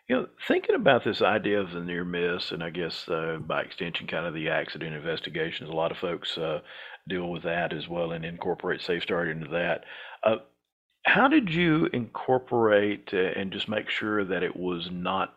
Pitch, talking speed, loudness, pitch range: 95 Hz, 190 wpm, -28 LUFS, 85-110 Hz